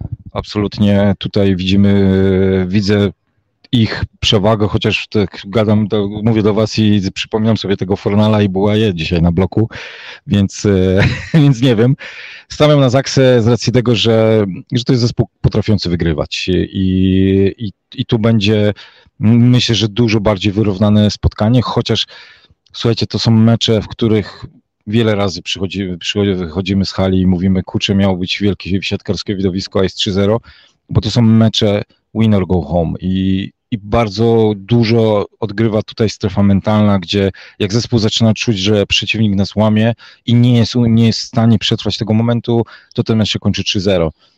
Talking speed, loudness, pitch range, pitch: 160 wpm, -14 LUFS, 100-115 Hz, 105 Hz